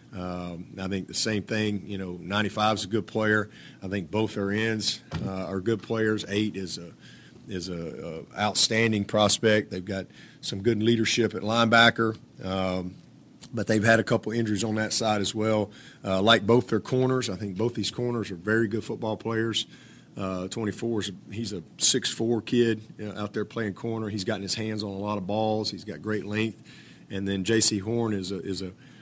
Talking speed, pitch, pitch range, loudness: 205 wpm, 110 Hz, 100-115 Hz, -26 LUFS